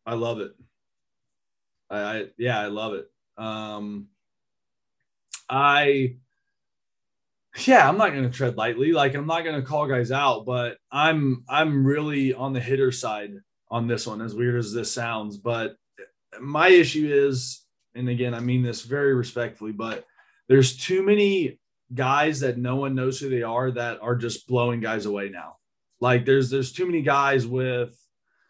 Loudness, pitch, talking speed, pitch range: -23 LUFS, 125 Hz, 165 wpm, 115-140 Hz